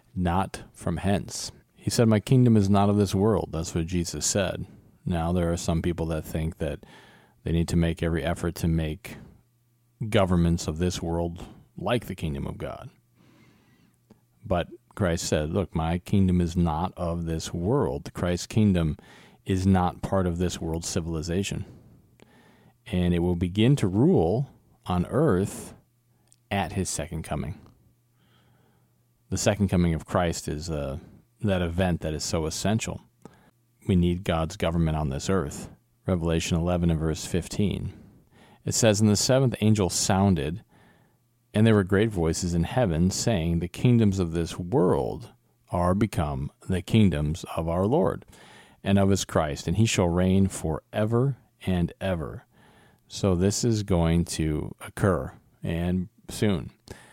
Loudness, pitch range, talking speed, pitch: -26 LUFS, 85-105 Hz, 150 wpm, 90 Hz